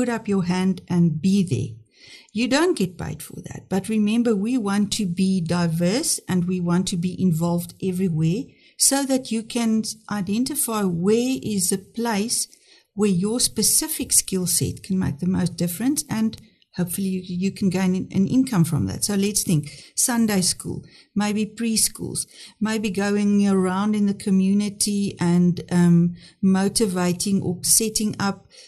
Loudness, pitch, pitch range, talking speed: -22 LUFS, 195 Hz, 180-220 Hz, 155 wpm